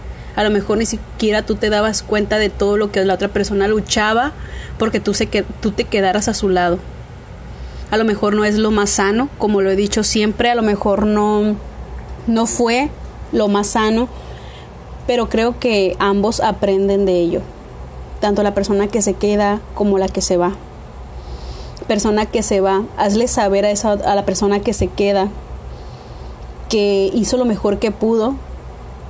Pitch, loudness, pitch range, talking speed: 205 Hz, -16 LUFS, 195-220 Hz, 180 wpm